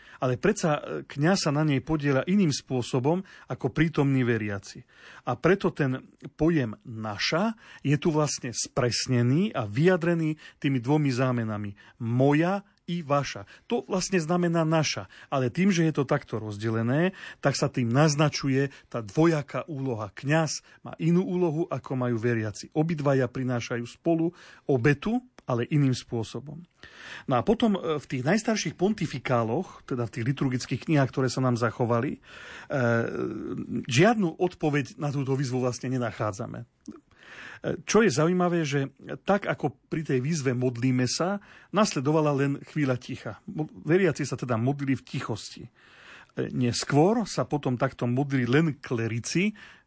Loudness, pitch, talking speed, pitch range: -27 LUFS, 140 Hz, 135 wpm, 125-165 Hz